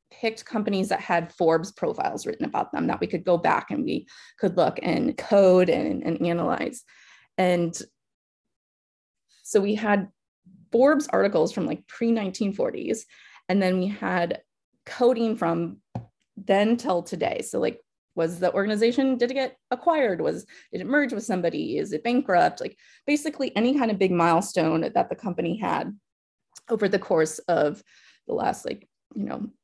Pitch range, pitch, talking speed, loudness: 170-240 Hz, 200 Hz, 160 wpm, -25 LUFS